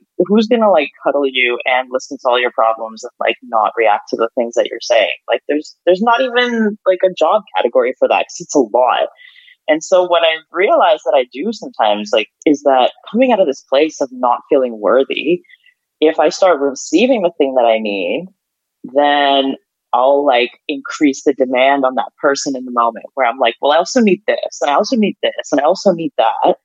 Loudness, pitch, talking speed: -14 LUFS, 160 Hz, 220 wpm